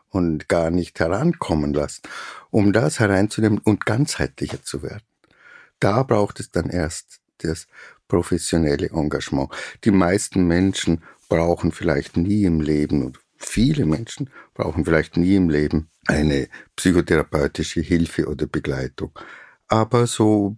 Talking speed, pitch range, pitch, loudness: 125 wpm, 80-105 Hz, 85 Hz, -21 LUFS